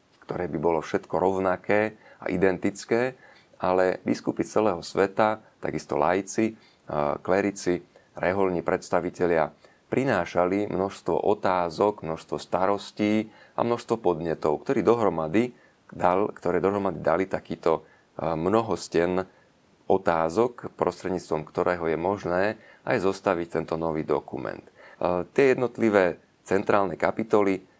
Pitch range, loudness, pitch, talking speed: 85-105 Hz, -26 LUFS, 95 Hz, 100 wpm